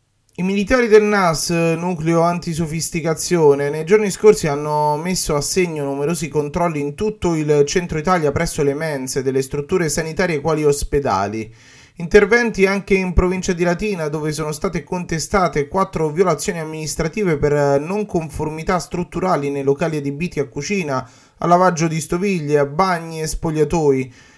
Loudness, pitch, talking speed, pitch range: -18 LUFS, 165 Hz, 145 wpm, 145-185 Hz